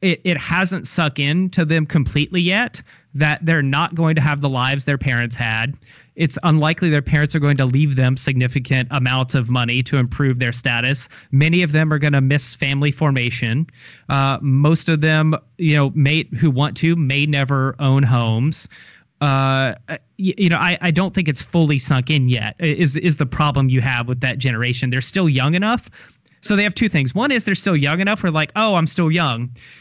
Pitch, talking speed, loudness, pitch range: 145 Hz, 205 wpm, -18 LUFS, 135-165 Hz